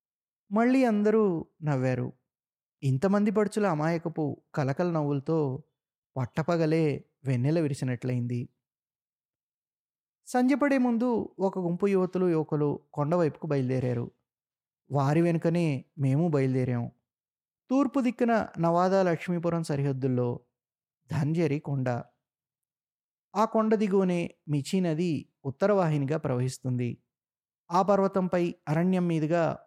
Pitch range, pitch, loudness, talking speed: 135-185 Hz, 155 Hz, -28 LUFS, 85 wpm